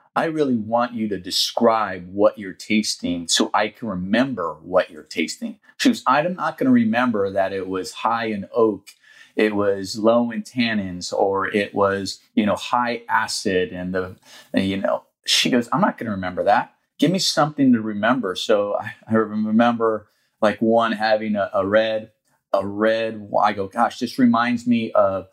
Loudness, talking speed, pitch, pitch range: -21 LUFS, 180 wpm, 110 Hz, 100-120 Hz